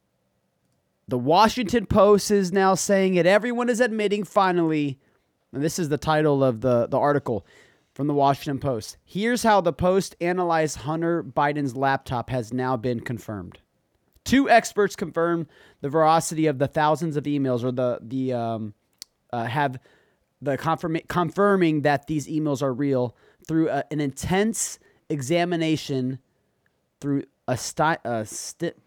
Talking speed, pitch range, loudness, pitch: 145 wpm, 130-180 Hz, -23 LUFS, 155 Hz